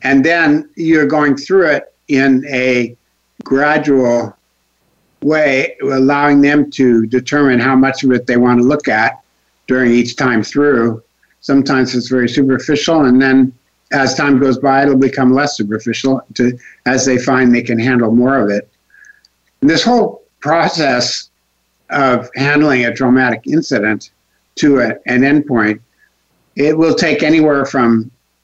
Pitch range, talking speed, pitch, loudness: 120-145 Hz, 145 wpm, 130 Hz, -12 LUFS